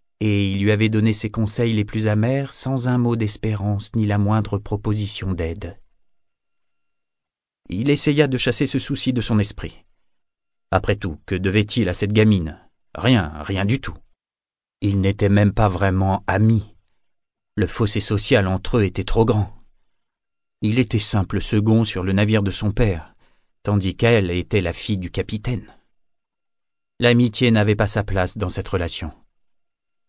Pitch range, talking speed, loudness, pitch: 95-110 Hz, 155 wpm, -20 LUFS, 105 Hz